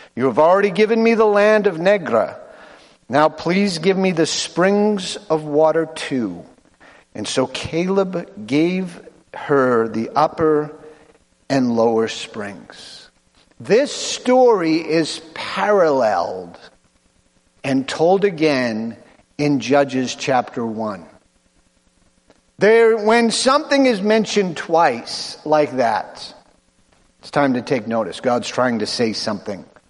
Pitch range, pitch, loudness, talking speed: 130-200 Hz, 155 Hz, -18 LUFS, 115 wpm